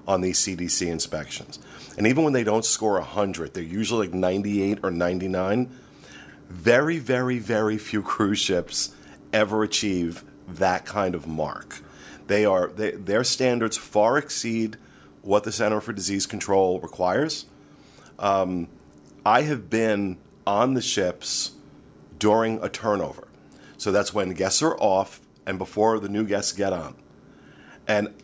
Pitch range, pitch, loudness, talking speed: 90-110 Hz, 100 Hz, -24 LUFS, 140 wpm